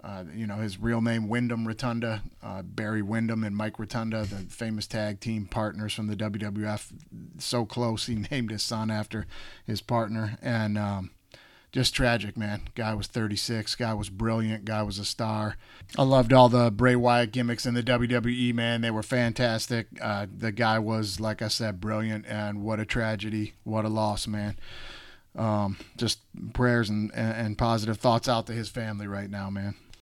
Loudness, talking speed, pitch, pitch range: -28 LUFS, 180 wpm, 110 Hz, 105-115 Hz